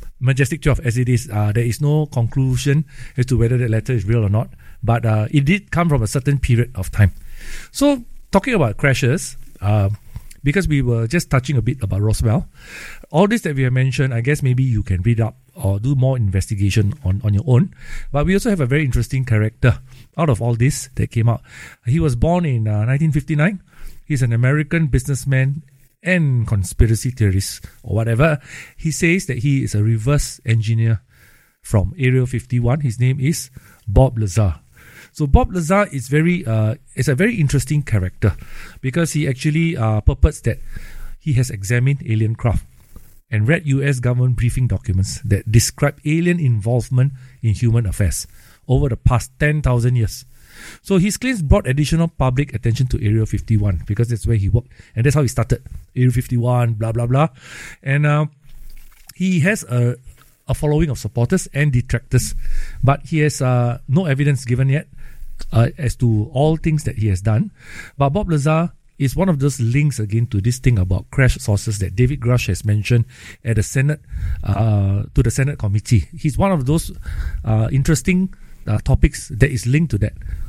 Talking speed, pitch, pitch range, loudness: 185 wpm, 125 Hz, 110-145 Hz, -18 LUFS